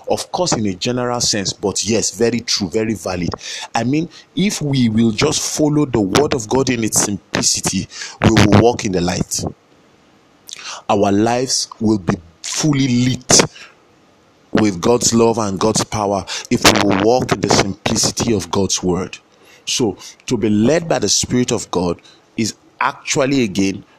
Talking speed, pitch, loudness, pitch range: 165 wpm, 110 Hz, -16 LUFS, 100-125 Hz